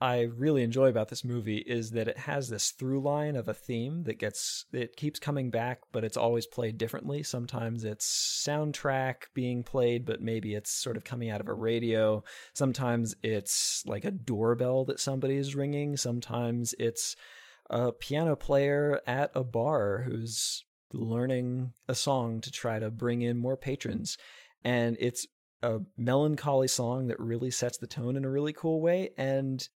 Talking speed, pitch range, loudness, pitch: 175 wpm, 115-135 Hz, -31 LUFS, 125 Hz